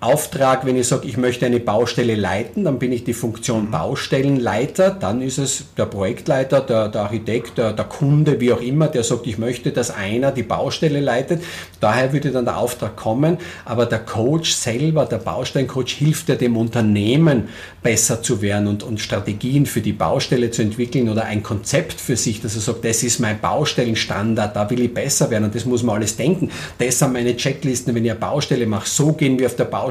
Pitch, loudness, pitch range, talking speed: 120 Hz, -19 LUFS, 110-135 Hz, 205 wpm